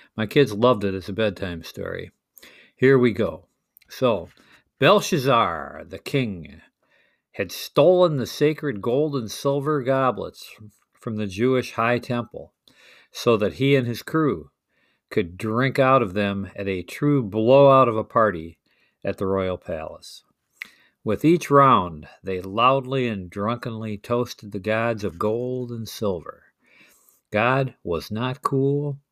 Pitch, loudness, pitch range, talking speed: 120 Hz, -22 LUFS, 105-135 Hz, 140 wpm